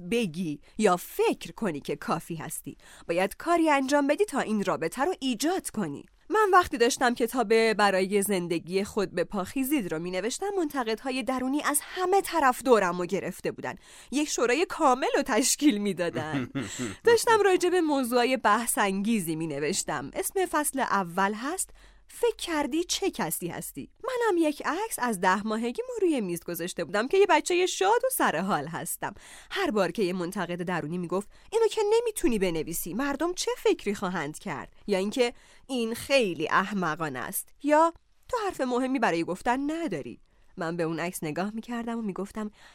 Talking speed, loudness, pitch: 165 wpm, -27 LUFS, 235 Hz